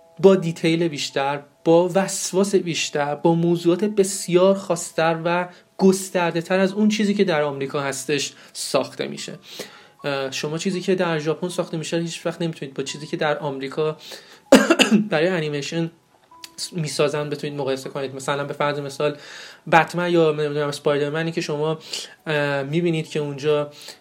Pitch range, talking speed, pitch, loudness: 145-180 Hz, 140 wpm, 165 Hz, -22 LUFS